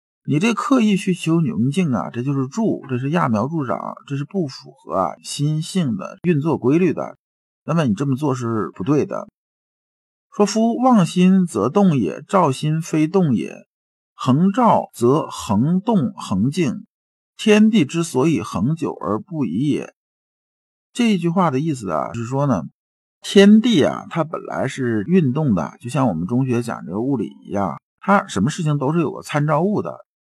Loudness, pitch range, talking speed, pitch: -19 LUFS, 140-200 Hz, 240 characters per minute, 170 Hz